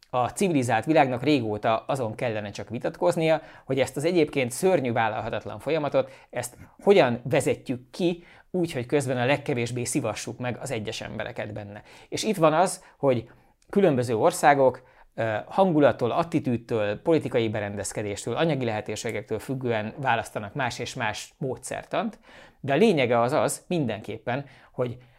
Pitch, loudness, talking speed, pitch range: 125 Hz, -26 LUFS, 135 wpm, 110-150 Hz